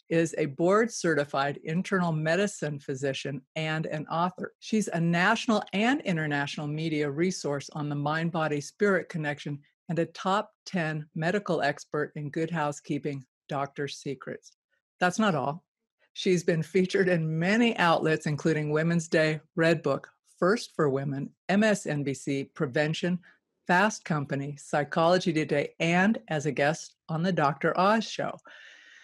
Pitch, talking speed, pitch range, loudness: 160 Hz, 135 wpm, 150-185 Hz, -28 LUFS